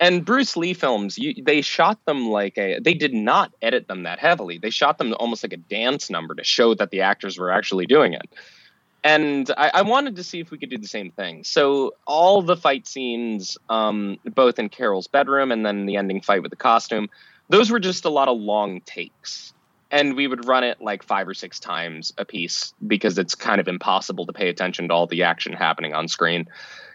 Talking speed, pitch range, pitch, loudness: 225 wpm, 100-155 Hz, 130 Hz, -21 LUFS